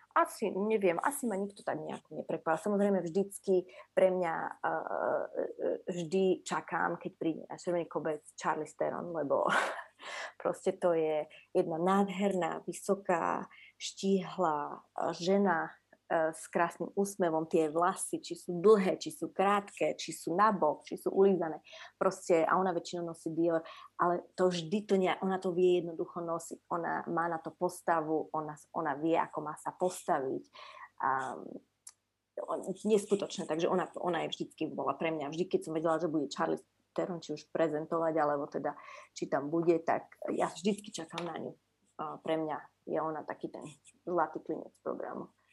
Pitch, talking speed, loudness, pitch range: 175 Hz, 155 wpm, -33 LUFS, 165-195 Hz